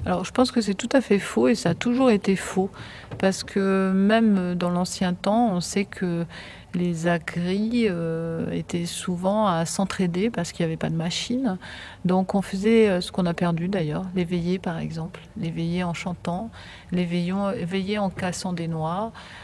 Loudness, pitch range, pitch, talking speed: -24 LUFS, 175-200 Hz, 185 Hz, 180 wpm